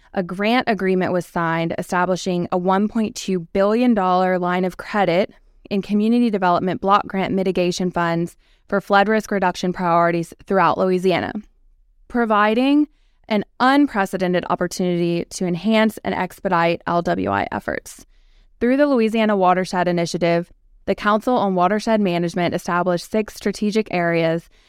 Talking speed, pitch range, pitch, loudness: 120 wpm, 175-210 Hz, 185 Hz, -19 LUFS